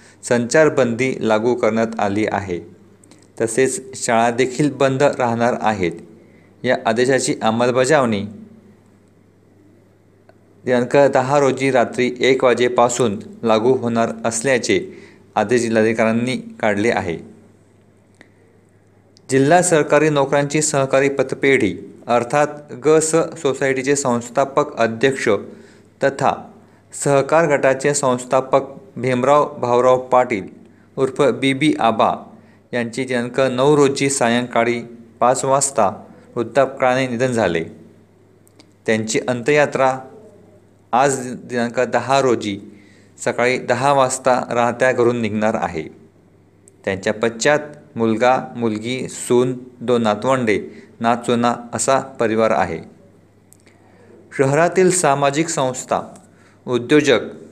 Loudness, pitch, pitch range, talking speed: -18 LUFS, 120 Hz, 110-135 Hz, 90 wpm